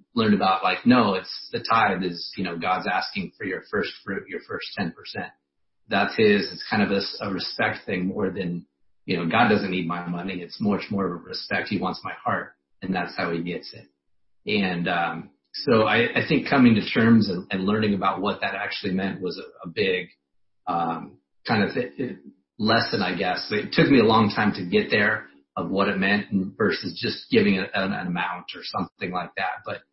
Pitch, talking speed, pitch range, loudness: 95 Hz, 215 wpm, 85-100 Hz, -24 LUFS